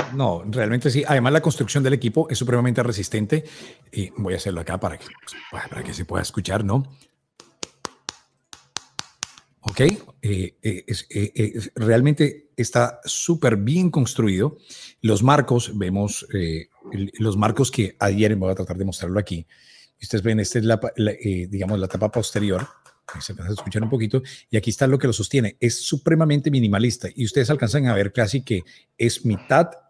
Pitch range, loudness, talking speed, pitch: 100-135 Hz, -22 LUFS, 170 wpm, 115 Hz